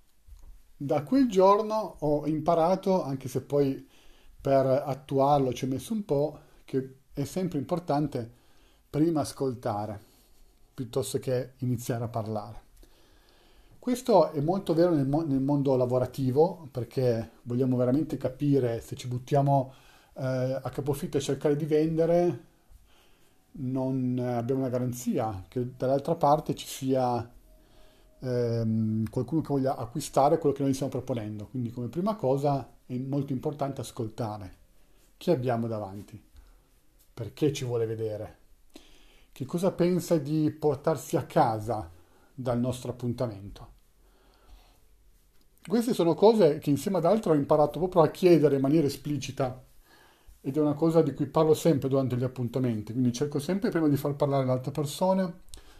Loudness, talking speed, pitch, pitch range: -28 LUFS, 135 wpm, 135 Hz, 120-155 Hz